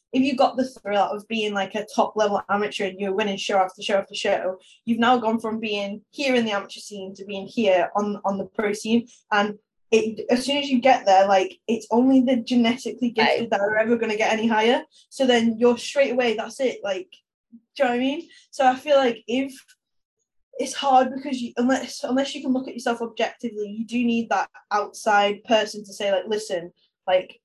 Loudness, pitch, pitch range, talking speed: -23 LUFS, 225 Hz, 205-255 Hz, 220 wpm